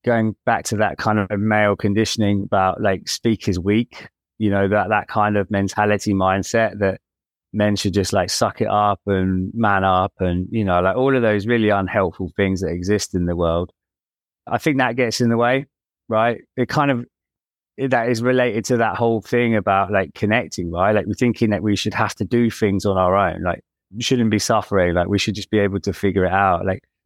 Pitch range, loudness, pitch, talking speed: 95-115 Hz, -19 LUFS, 105 Hz, 215 wpm